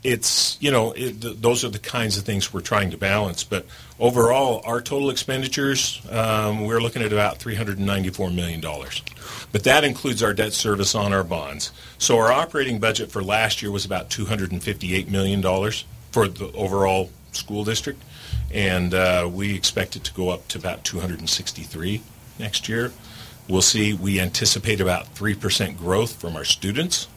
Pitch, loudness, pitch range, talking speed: 105 Hz, -22 LUFS, 95-115 Hz, 170 wpm